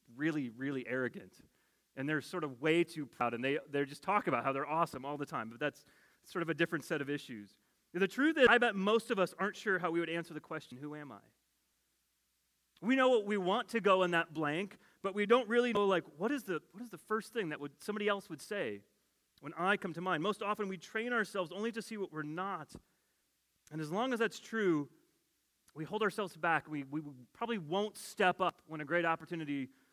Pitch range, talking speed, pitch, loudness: 150-210 Hz, 235 wpm, 170 Hz, -35 LUFS